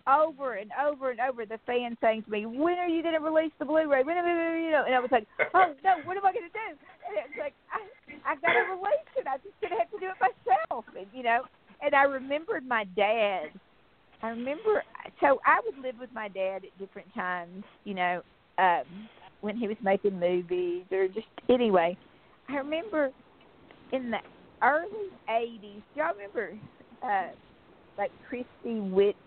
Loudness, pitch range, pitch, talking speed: -29 LUFS, 220-335 Hz, 265 Hz, 195 wpm